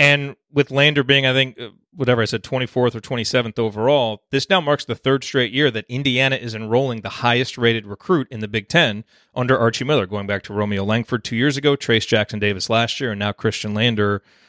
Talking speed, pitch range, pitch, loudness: 215 wpm, 110-135 Hz, 120 Hz, -19 LUFS